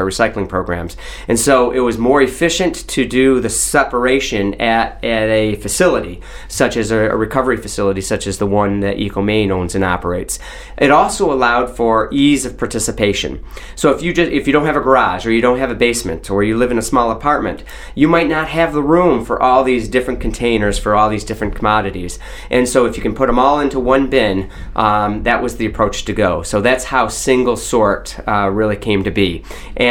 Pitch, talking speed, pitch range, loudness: 115 Hz, 215 wpm, 105-130 Hz, -15 LUFS